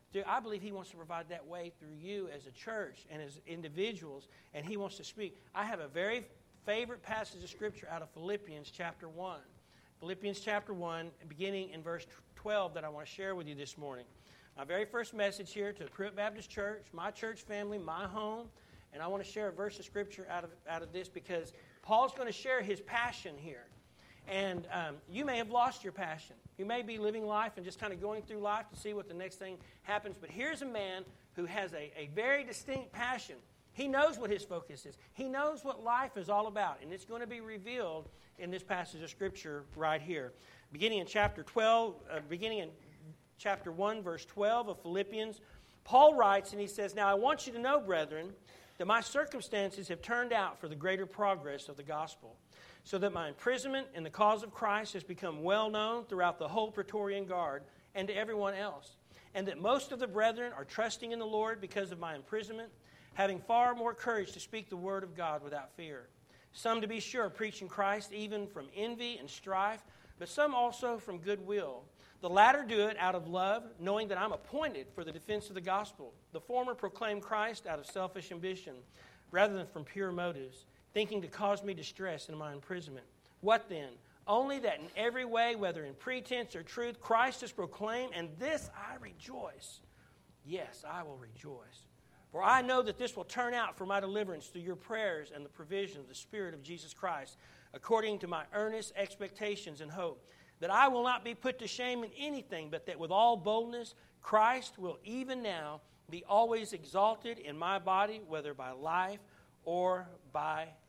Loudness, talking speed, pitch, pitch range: -36 LUFS, 205 wpm, 200 Hz, 170-220 Hz